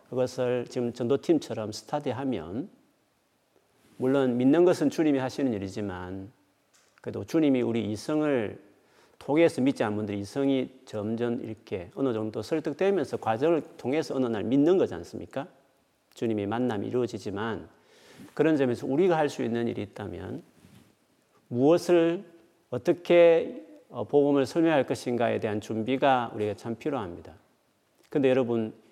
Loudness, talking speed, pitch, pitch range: -27 LUFS, 310 characters per minute, 125 Hz, 110-150 Hz